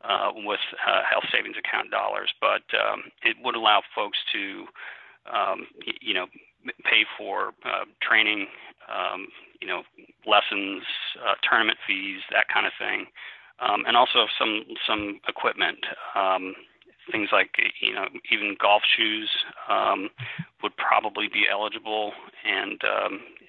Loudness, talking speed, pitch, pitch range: -24 LUFS, 135 wpm, 105 Hz, 100-110 Hz